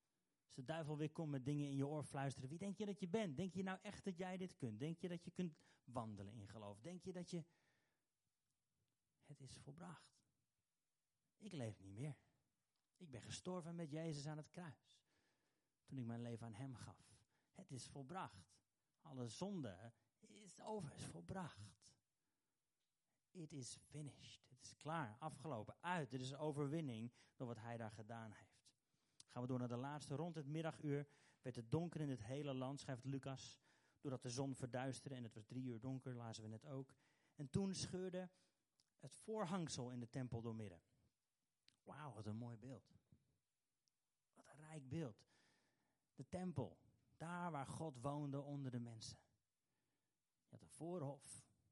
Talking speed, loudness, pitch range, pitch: 175 wpm, -51 LUFS, 125-160 Hz, 140 Hz